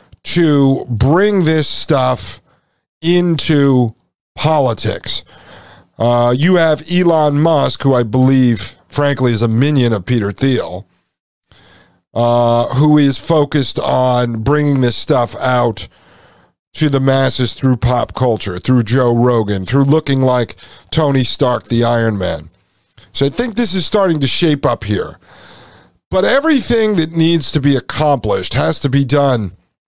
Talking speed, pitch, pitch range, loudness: 135 wpm, 130 Hz, 120-150 Hz, -14 LUFS